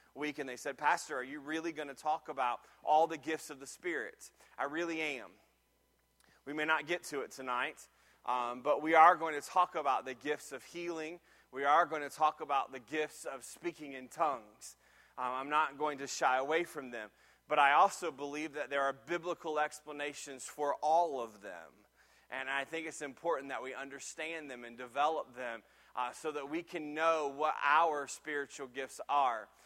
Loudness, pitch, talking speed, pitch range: -35 LUFS, 150 Hz, 195 wpm, 135-160 Hz